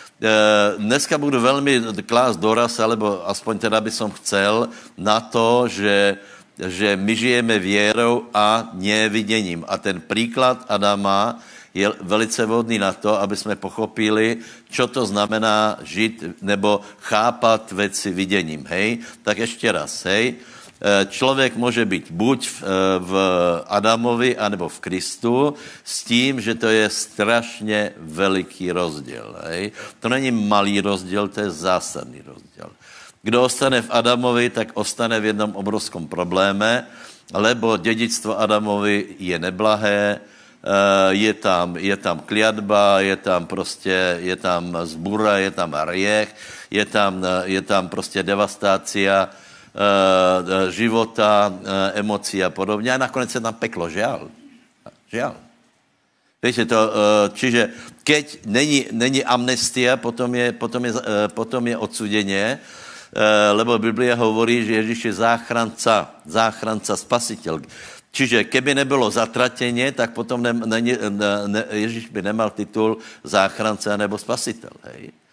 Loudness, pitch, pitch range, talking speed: -19 LUFS, 105 Hz, 100-115 Hz, 130 wpm